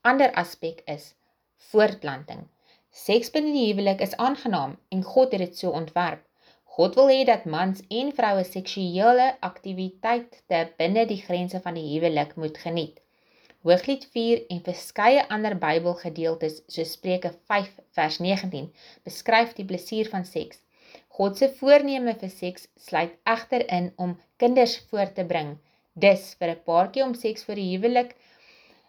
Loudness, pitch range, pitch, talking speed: -24 LUFS, 175-235 Hz, 190 Hz, 150 wpm